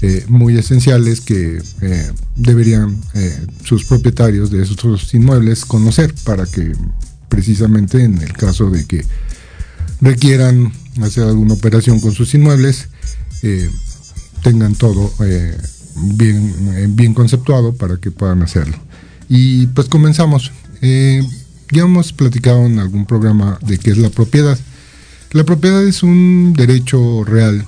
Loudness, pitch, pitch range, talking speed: -12 LUFS, 115 Hz, 100-130 Hz, 130 wpm